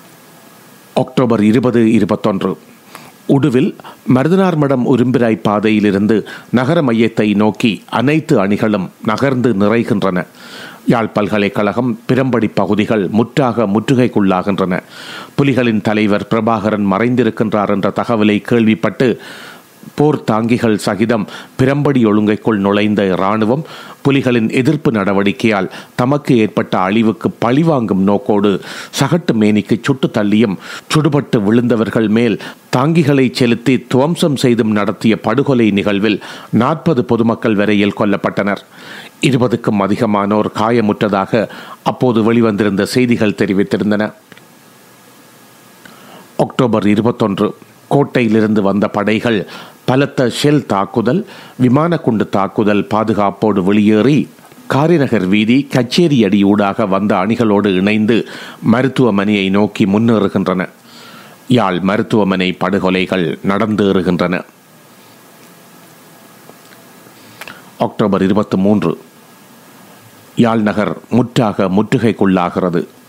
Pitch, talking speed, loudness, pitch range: 110 Hz, 80 wpm, -14 LUFS, 105-125 Hz